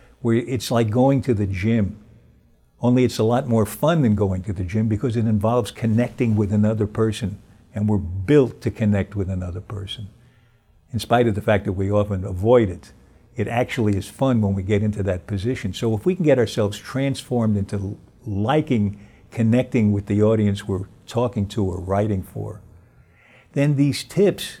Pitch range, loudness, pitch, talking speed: 100-120 Hz, -21 LUFS, 110 Hz, 185 wpm